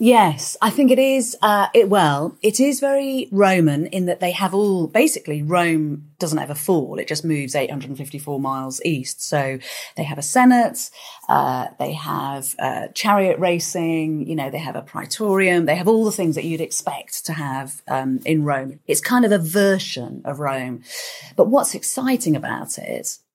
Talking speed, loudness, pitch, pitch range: 180 wpm, -20 LUFS, 165 Hz, 145-200 Hz